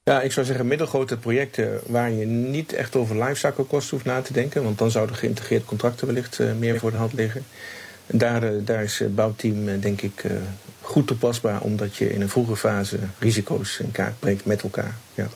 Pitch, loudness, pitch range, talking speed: 115 Hz, -24 LUFS, 105-130 Hz, 195 wpm